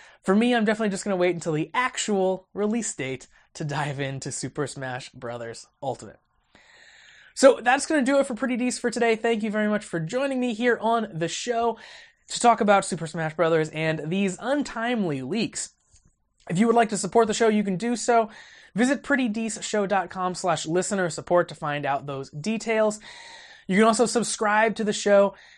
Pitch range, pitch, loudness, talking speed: 170-235 Hz, 210 Hz, -24 LUFS, 190 wpm